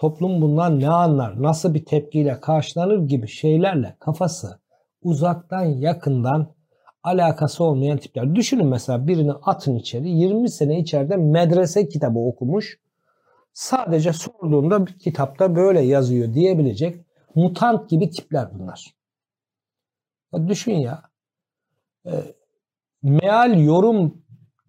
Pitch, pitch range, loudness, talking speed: 160 Hz, 145-180 Hz, -20 LUFS, 100 wpm